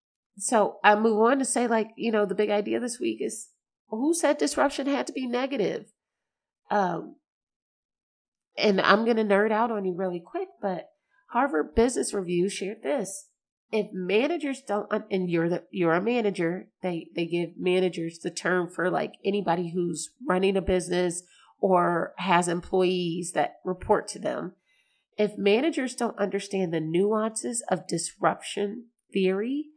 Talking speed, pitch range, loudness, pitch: 155 wpm, 180-230 Hz, -26 LUFS, 200 Hz